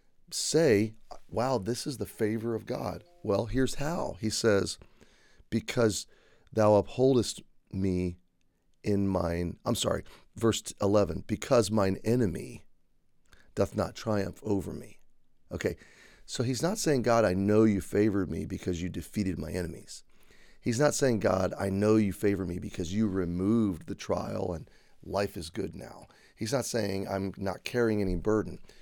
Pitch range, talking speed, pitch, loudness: 95-115 Hz, 155 wpm, 100 Hz, -30 LUFS